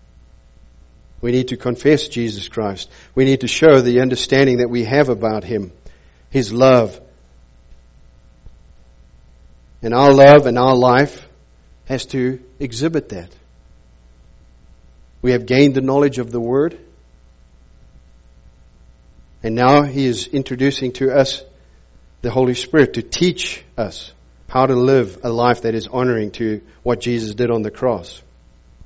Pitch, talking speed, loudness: 115 Hz, 135 wpm, -16 LUFS